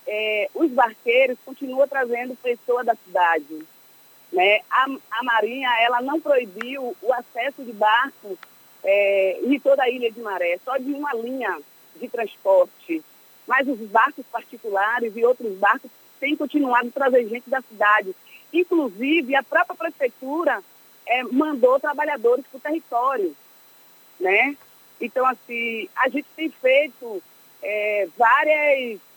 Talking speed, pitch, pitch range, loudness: 130 wpm, 255 Hz, 230-285 Hz, -21 LUFS